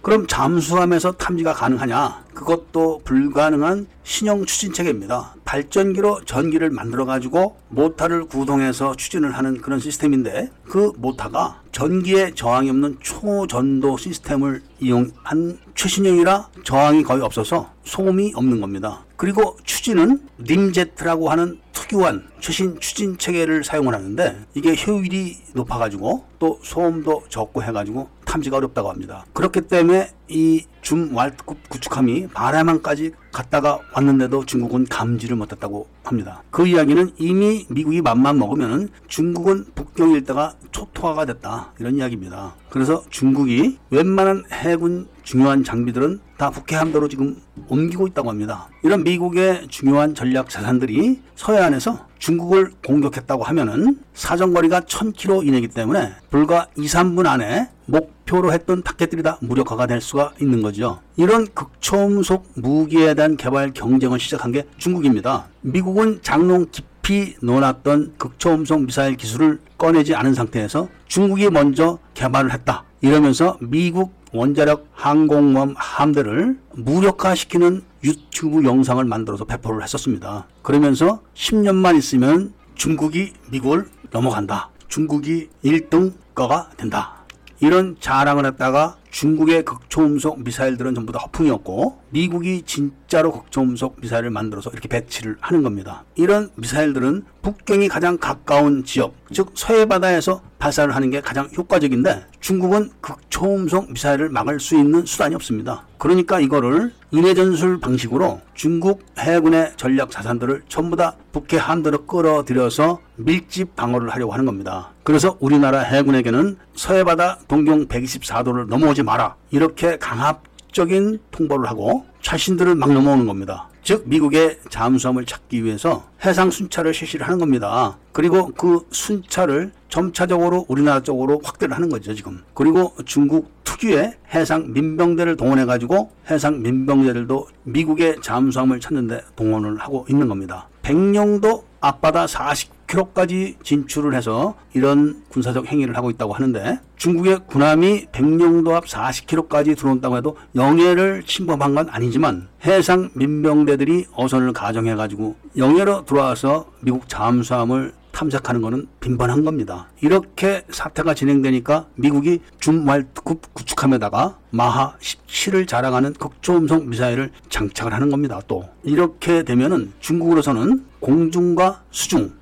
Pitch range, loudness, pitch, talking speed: 130-175 Hz, -18 LUFS, 150 Hz, 335 characters per minute